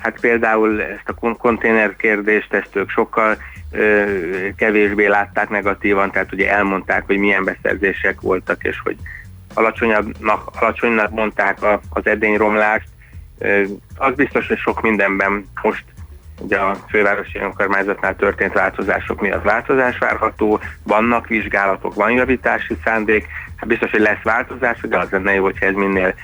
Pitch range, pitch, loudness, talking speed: 95-110 Hz, 105 Hz, -17 LUFS, 140 wpm